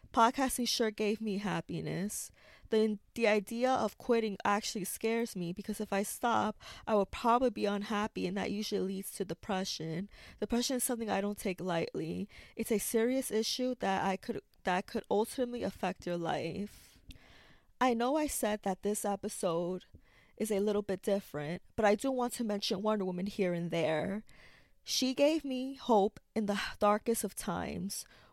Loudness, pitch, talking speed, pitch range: -34 LUFS, 210 Hz, 170 wpm, 195-230 Hz